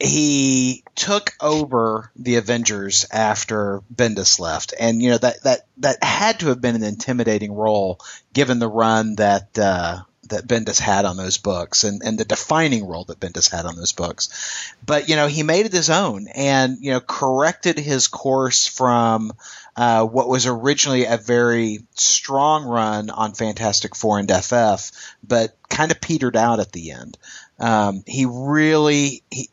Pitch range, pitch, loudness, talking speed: 105-135 Hz, 120 Hz, -18 LUFS, 170 wpm